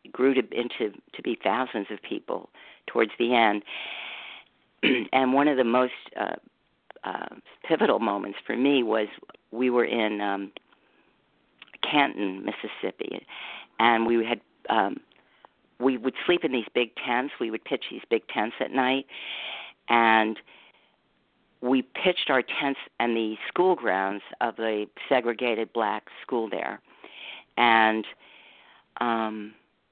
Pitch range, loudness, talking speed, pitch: 110-130 Hz, -26 LUFS, 130 wpm, 120 Hz